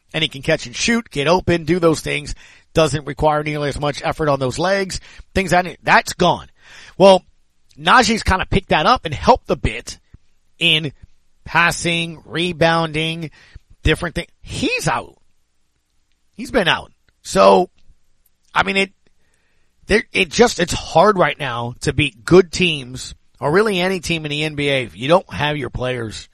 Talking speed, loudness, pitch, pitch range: 165 wpm, -17 LUFS, 160 Hz, 140-175 Hz